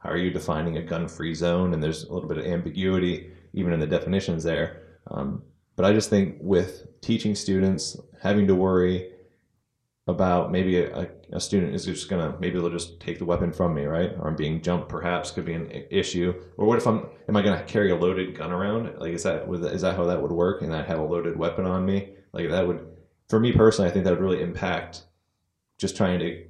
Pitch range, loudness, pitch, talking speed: 85-95 Hz, -25 LUFS, 90 Hz, 225 wpm